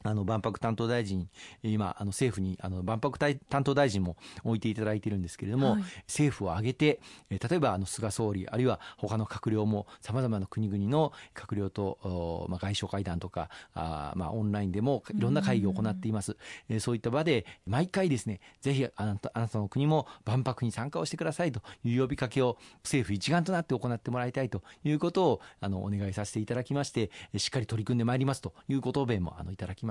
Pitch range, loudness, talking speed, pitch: 100-130 Hz, -32 LUFS, 400 characters per minute, 110 Hz